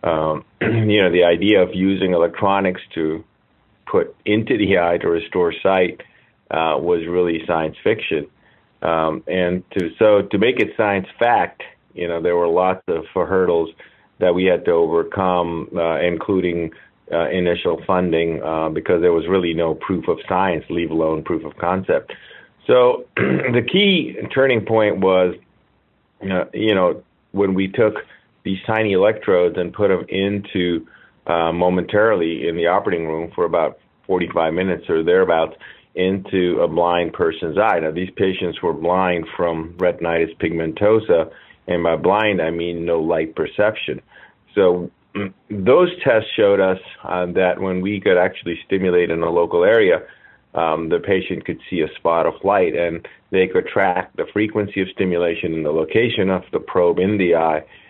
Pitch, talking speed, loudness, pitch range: 90 Hz, 165 wpm, -19 LUFS, 85-105 Hz